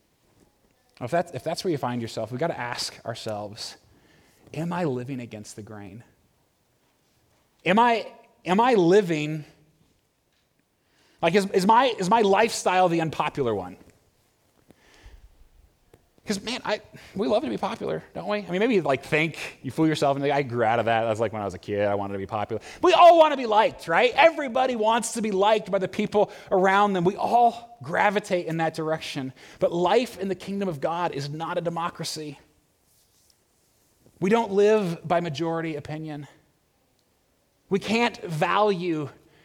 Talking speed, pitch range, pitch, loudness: 175 wpm, 140-210 Hz, 170 Hz, -24 LUFS